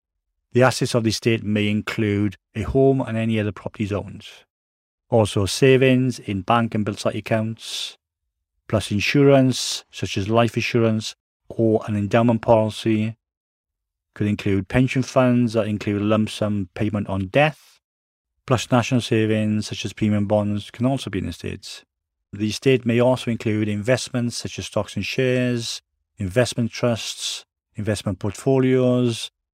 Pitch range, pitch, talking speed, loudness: 100-120 Hz, 110 Hz, 145 wpm, -21 LUFS